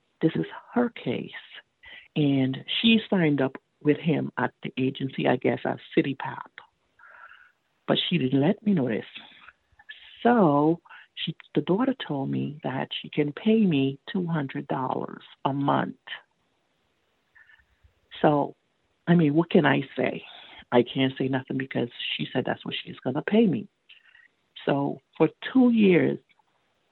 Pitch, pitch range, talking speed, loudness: 170 Hz, 140-230 Hz, 145 wpm, -26 LUFS